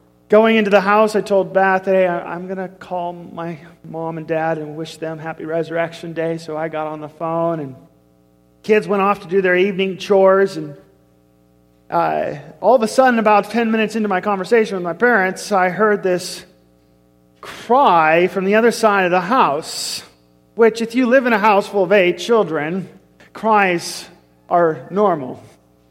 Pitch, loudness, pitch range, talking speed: 180 Hz, -17 LUFS, 160-205 Hz, 180 wpm